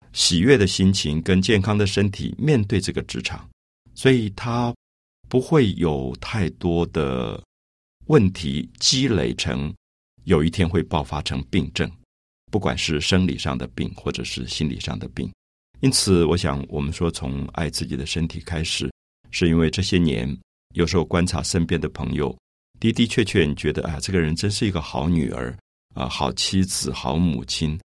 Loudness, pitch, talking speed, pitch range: -22 LUFS, 85 Hz, 240 characters per minute, 70-95 Hz